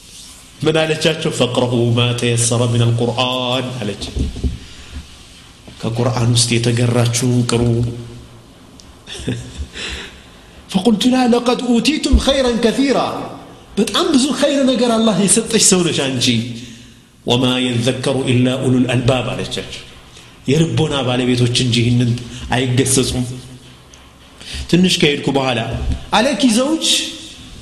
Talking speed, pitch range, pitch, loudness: 90 wpm, 120-175 Hz, 125 Hz, -15 LUFS